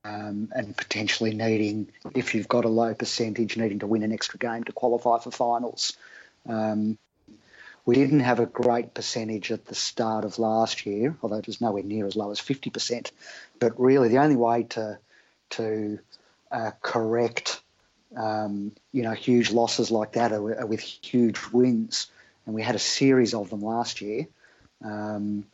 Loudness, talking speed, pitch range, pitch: -26 LUFS, 170 wpm, 110-120 Hz, 110 Hz